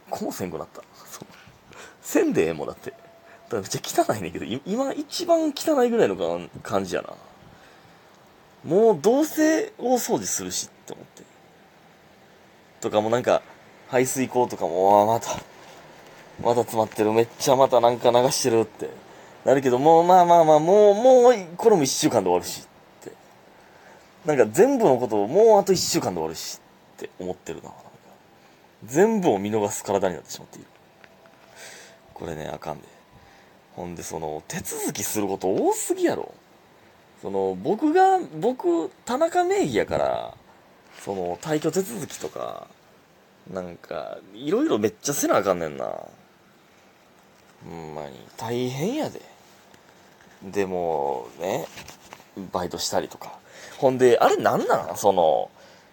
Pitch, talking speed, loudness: 125 Hz, 275 characters per minute, -22 LUFS